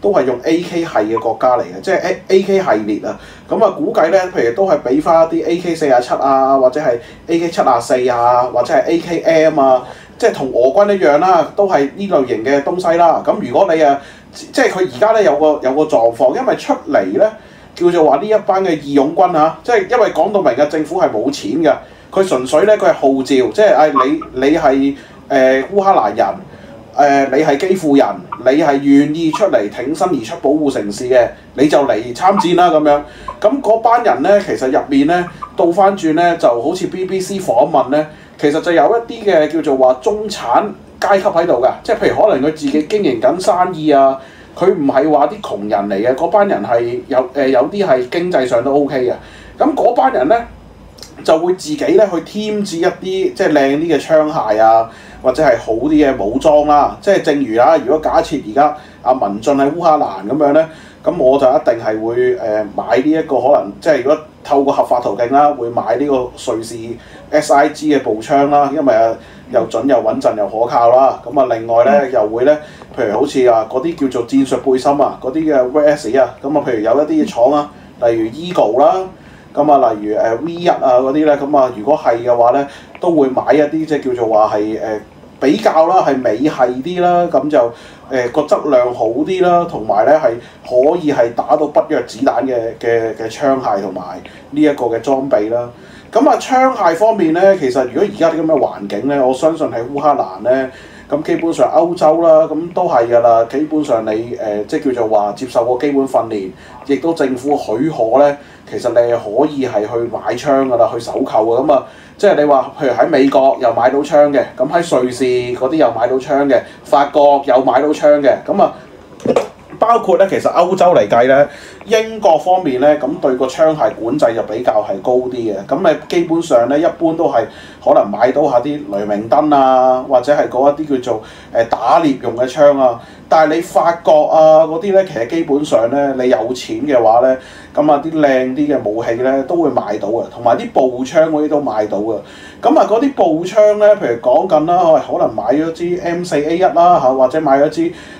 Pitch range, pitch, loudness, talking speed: 130-175 Hz, 150 Hz, -13 LUFS, 300 characters per minute